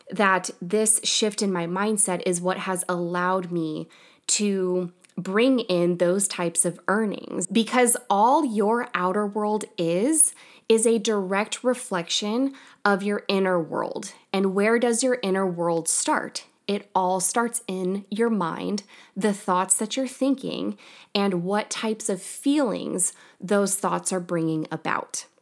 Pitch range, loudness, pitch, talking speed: 180-225 Hz, -24 LUFS, 200 Hz, 140 wpm